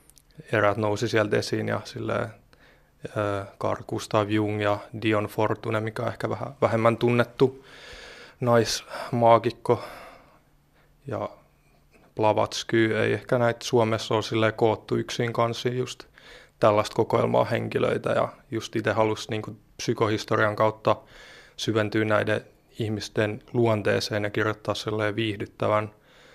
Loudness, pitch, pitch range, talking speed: -25 LUFS, 110 Hz, 105-115 Hz, 110 wpm